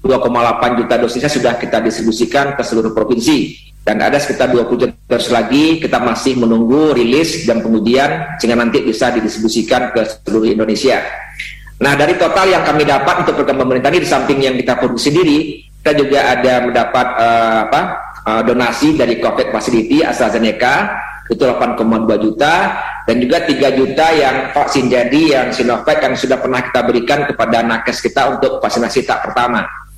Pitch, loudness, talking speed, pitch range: 130 Hz, -13 LUFS, 160 wpm, 115-145 Hz